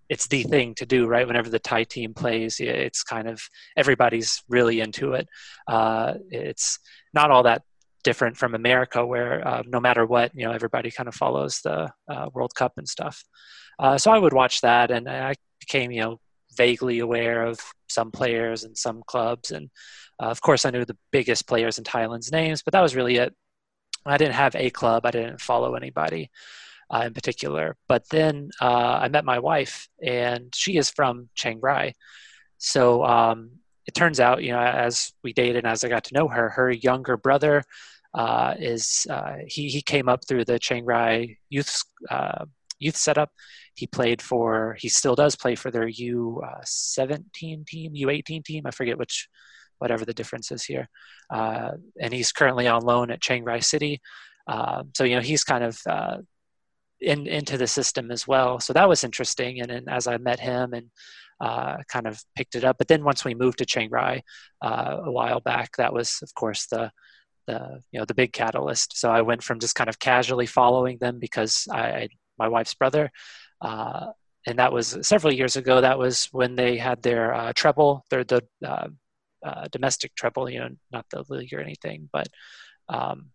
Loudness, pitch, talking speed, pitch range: -23 LUFS, 125 Hz, 195 wpm, 115-130 Hz